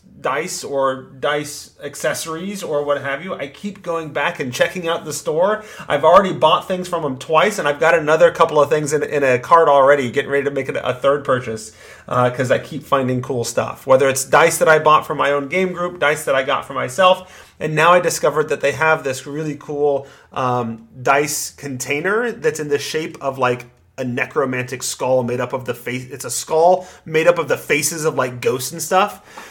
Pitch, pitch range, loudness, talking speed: 145 Hz, 130-170 Hz, -18 LUFS, 220 wpm